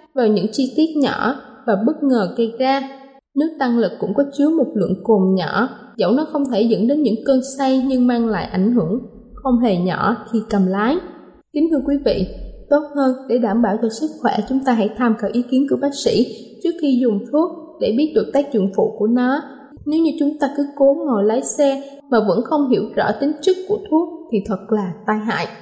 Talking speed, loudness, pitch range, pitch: 225 wpm, -18 LUFS, 220-285 Hz, 255 Hz